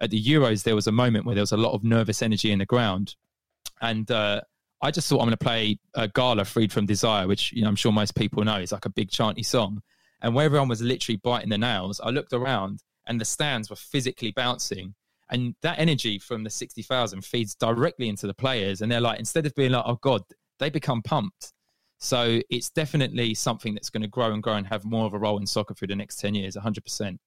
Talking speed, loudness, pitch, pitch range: 240 wpm, -25 LUFS, 115 Hz, 105-125 Hz